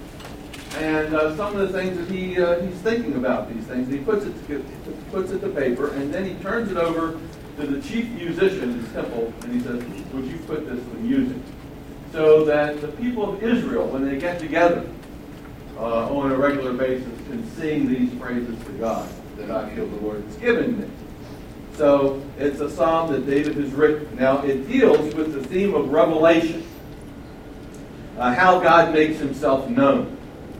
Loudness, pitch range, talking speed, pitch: -22 LUFS, 140-185 Hz, 190 wpm, 155 Hz